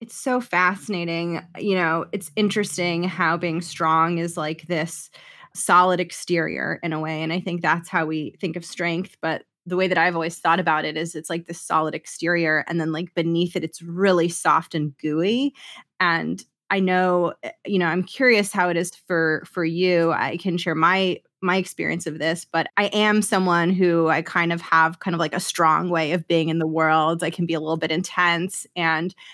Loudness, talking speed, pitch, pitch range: -22 LUFS, 205 wpm, 170 Hz, 165-185 Hz